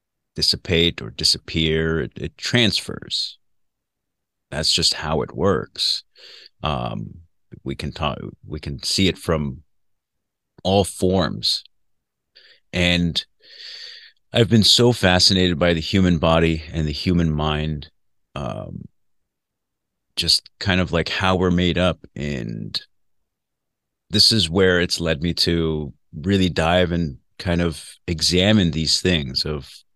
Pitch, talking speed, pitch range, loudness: 85 Hz, 120 wpm, 80-95 Hz, -19 LUFS